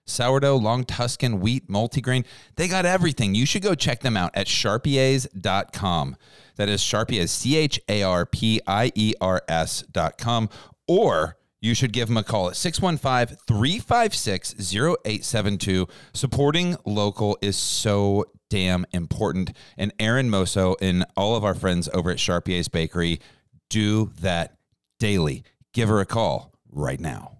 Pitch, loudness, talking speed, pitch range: 110 Hz, -23 LUFS, 140 wpm, 95-130 Hz